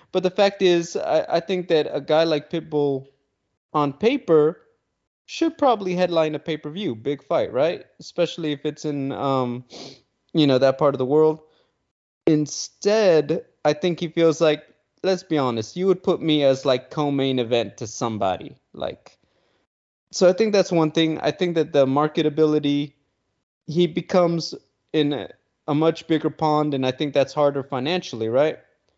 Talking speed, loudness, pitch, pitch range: 165 wpm, -22 LUFS, 155 Hz, 140-170 Hz